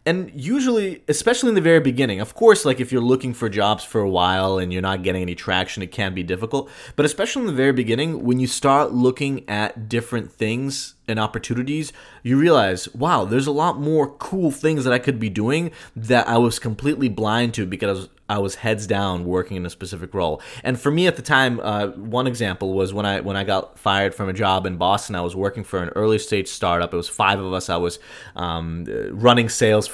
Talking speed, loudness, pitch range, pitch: 225 wpm, -21 LUFS, 95-135 Hz, 115 Hz